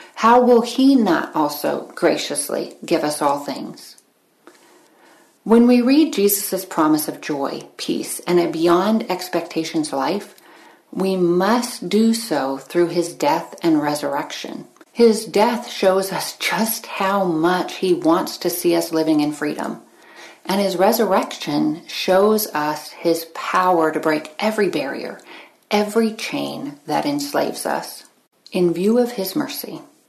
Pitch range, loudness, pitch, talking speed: 170-235 Hz, -19 LUFS, 195 Hz, 135 wpm